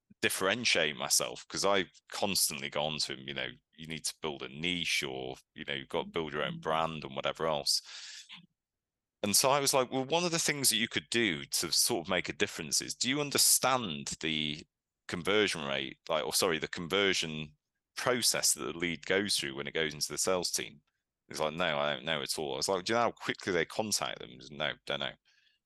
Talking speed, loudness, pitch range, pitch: 230 wpm, -31 LUFS, 75-105 Hz, 80 Hz